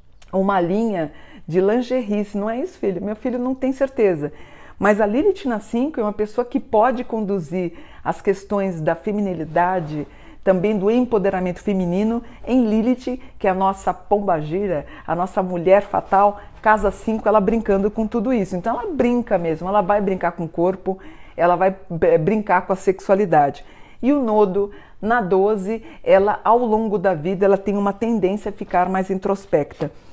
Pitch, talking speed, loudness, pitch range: 205 Hz, 165 wpm, -20 LUFS, 190-220 Hz